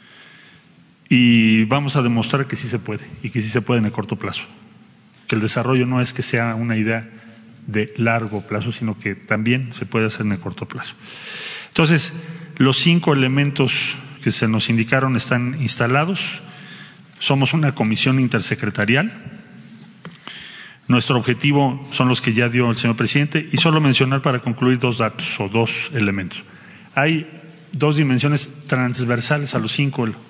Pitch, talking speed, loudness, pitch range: 125 Hz, 160 wpm, -19 LUFS, 115-145 Hz